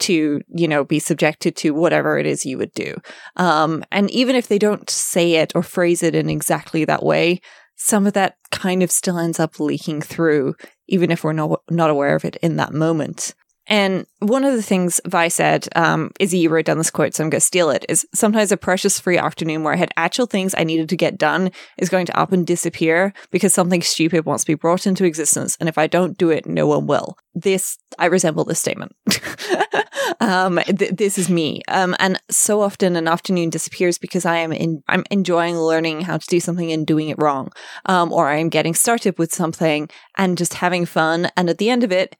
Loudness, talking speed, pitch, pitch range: -18 LUFS, 225 wpm, 175 Hz, 160-190 Hz